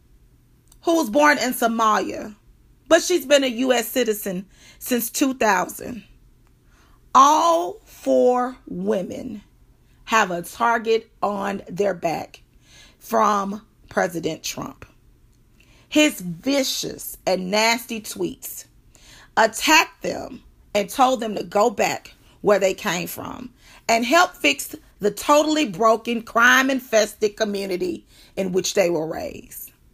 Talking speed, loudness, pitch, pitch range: 110 wpm, -20 LUFS, 230 Hz, 205-270 Hz